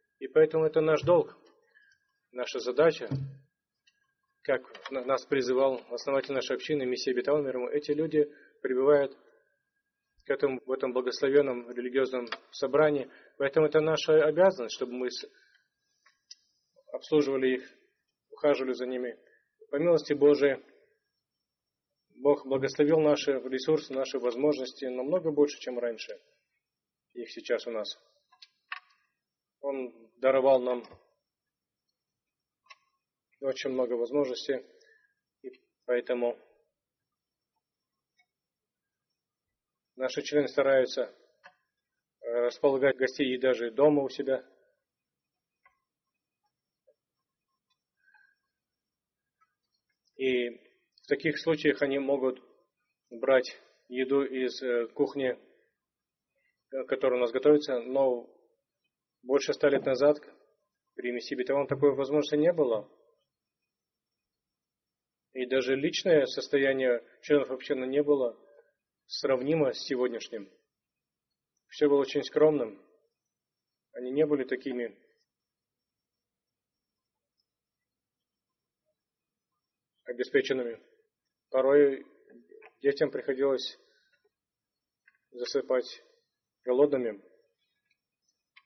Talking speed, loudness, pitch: 85 wpm, -29 LUFS, 145 Hz